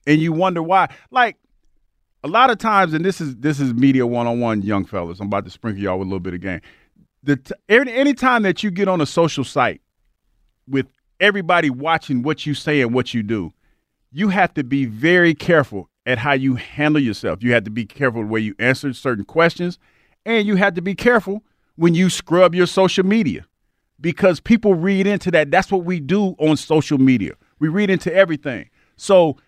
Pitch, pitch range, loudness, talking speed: 155 Hz, 125-190 Hz, -18 LUFS, 210 wpm